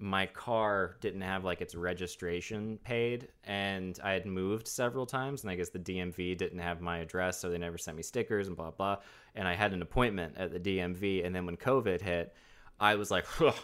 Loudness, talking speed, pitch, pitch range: -34 LUFS, 215 wpm, 95 Hz, 90-100 Hz